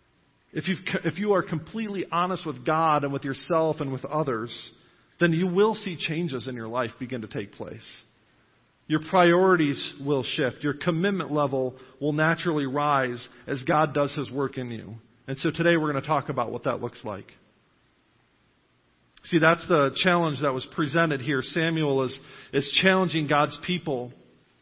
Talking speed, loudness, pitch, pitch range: 170 wpm, -25 LUFS, 145 Hz, 130-165 Hz